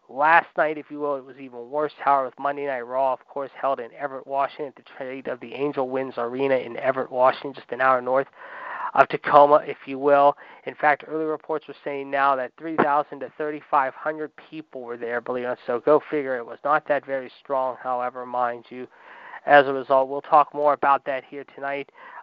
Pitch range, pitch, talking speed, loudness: 130-145 Hz, 140 Hz, 220 wpm, -23 LUFS